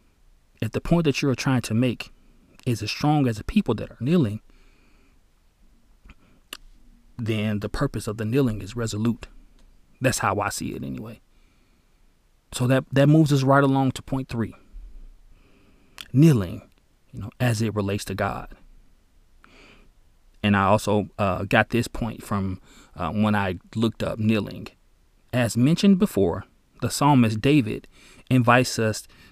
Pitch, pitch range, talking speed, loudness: 110 Hz, 100-130 Hz, 145 wpm, -23 LUFS